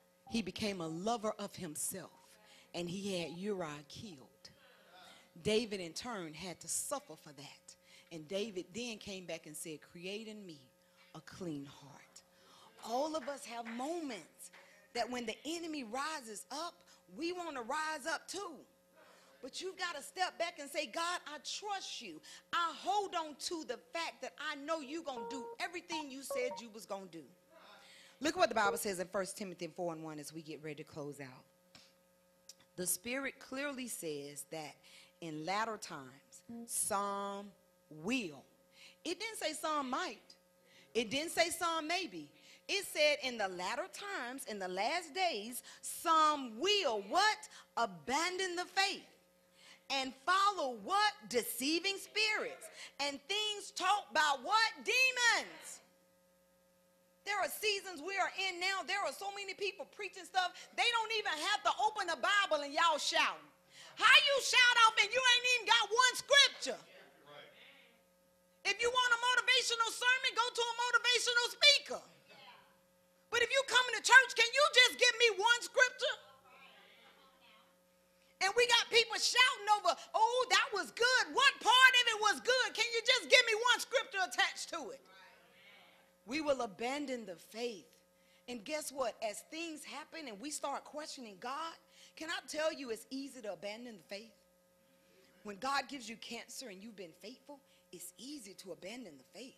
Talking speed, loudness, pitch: 165 wpm, -34 LUFS, 285 Hz